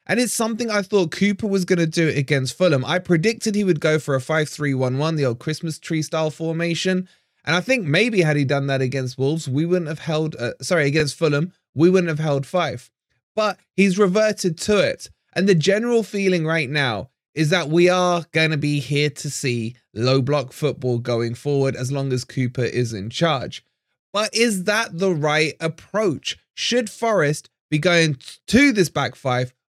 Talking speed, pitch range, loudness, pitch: 200 wpm, 135-185 Hz, -20 LUFS, 160 Hz